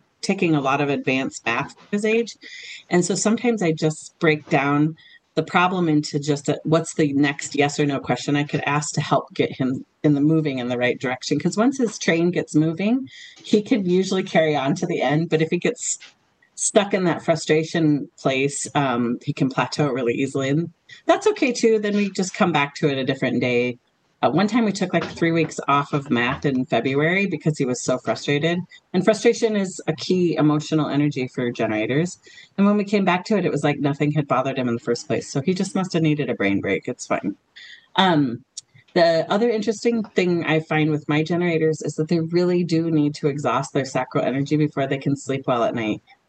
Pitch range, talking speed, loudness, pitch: 140-185 Hz, 220 wpm, -21 LUFS, 155 Hz